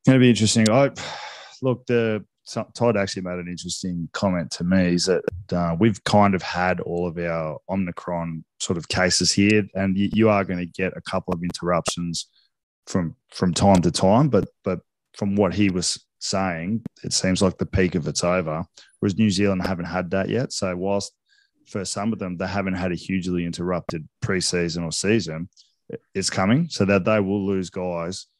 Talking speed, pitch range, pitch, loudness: 190 wpm, 90-100 Hz, 95 Hz, -23 LUFS